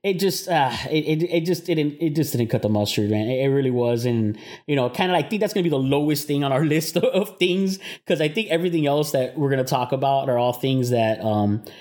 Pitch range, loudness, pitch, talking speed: 125-170 Hz, -22 LUFS, 145 Hz, 285 wpm